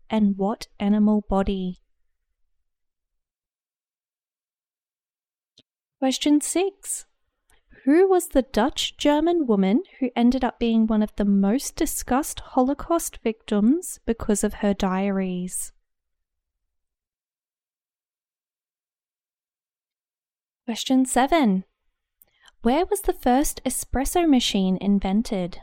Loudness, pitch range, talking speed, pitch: -23 LUFS, 195-270 Hz, 85 wpm, 225 Hz